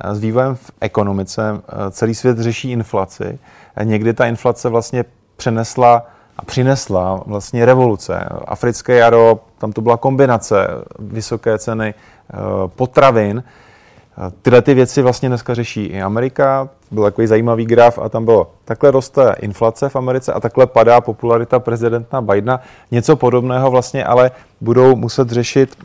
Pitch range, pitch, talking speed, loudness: 110-125 Hz, 120 Hz, 135 wpm, -14 LUFS